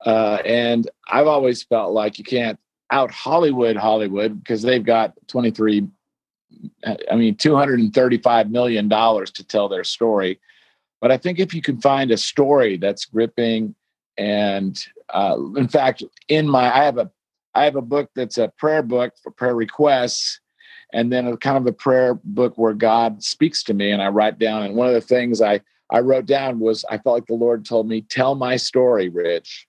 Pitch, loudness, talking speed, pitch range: 120 Hz, -19 LUFS, 190 wpm, 110-140 Hz